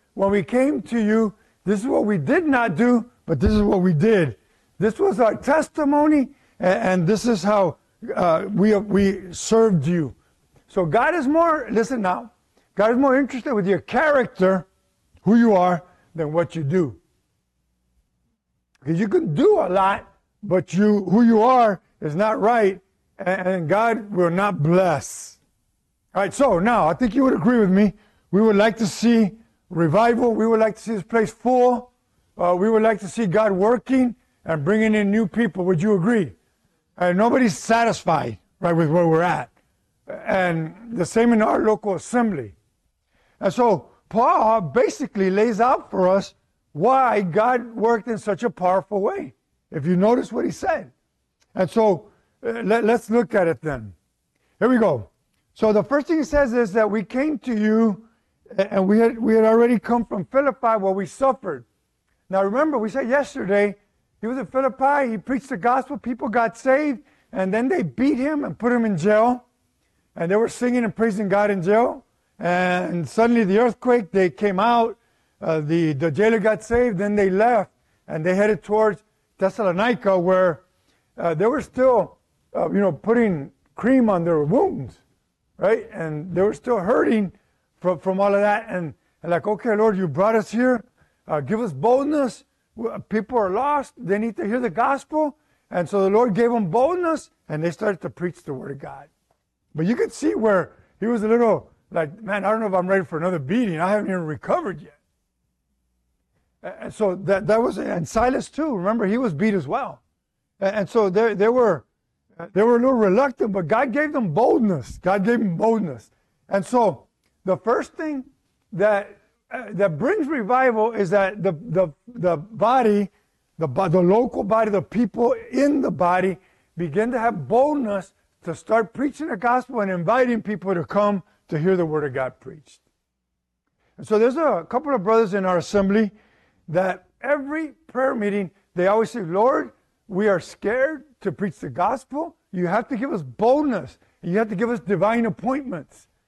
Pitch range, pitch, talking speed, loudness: 185-235 Hz, 210 Hz, 180 wpm, -21 LUFS